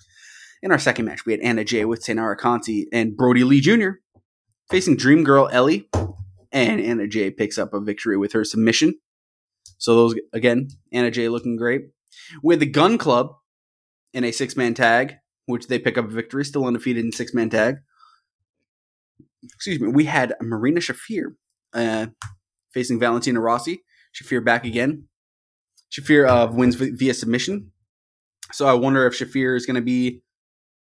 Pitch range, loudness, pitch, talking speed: 110-130 Hz, -20 LUFS, 120 Hz, 165 wpm